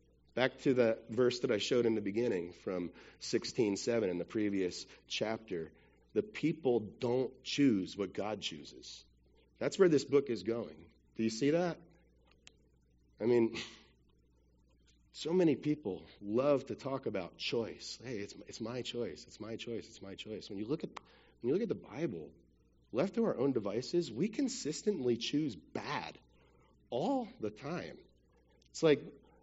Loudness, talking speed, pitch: -36 LUFS, 160 wpm, 115 Hz